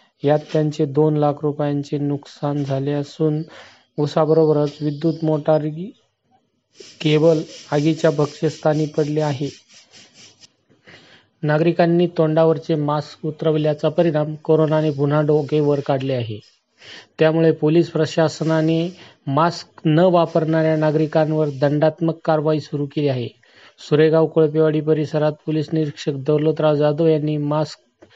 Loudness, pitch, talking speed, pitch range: -19 LUFS, 155 Hz, 95 wpm, 150-160 Hz